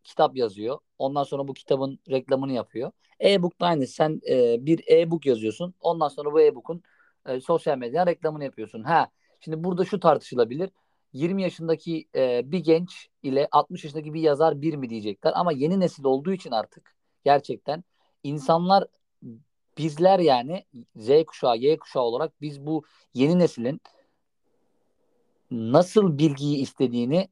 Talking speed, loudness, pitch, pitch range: 145 wpm, -24 LUFS, 160 Hz, 140-180 Hz